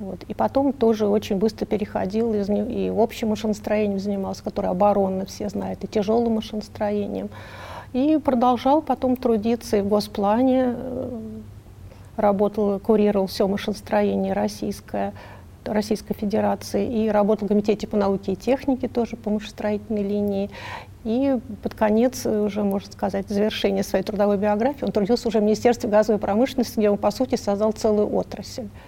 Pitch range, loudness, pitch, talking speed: 200-230 Hz, -23 LUFS, 210 Hz, 140 wpm